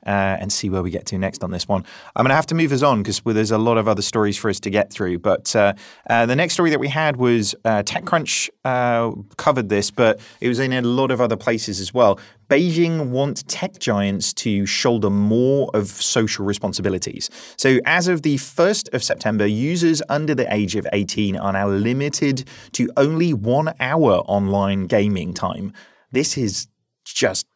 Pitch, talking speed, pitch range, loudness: 115 Hz, 205 wpm, 100-140 Hz, -19 LUFS